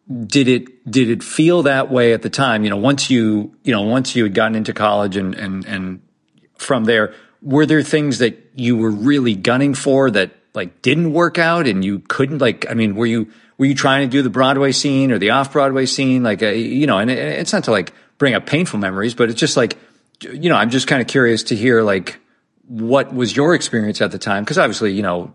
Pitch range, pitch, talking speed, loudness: 110-135 Hz, 125 Hz, 235 wpm, -16 LUFS